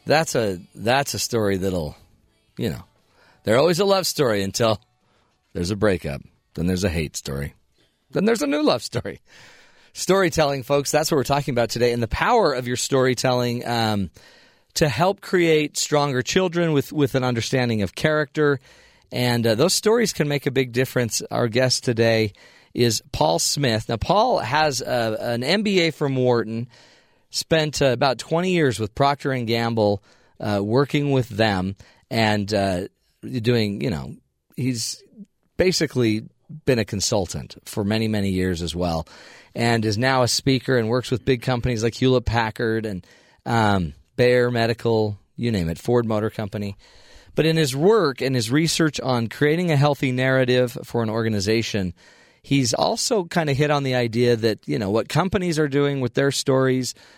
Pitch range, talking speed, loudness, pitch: 110-145 Hz, 165 wpm, -21 LUFS, 125 Hz